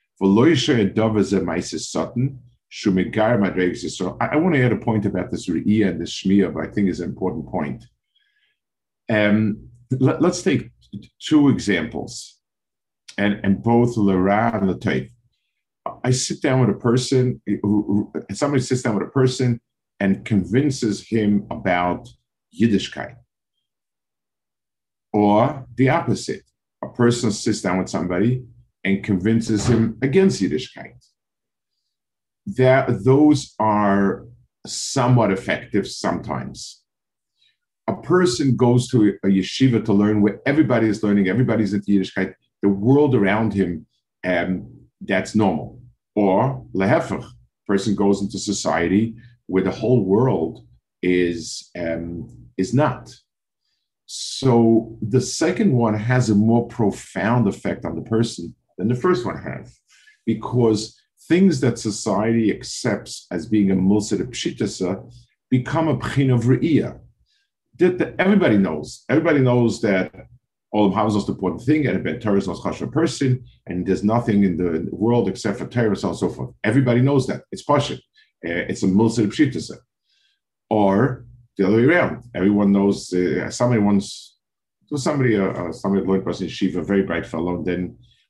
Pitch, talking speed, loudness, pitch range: 110 Hz, 135 wpm, -20 LUFS, 100-125 Hz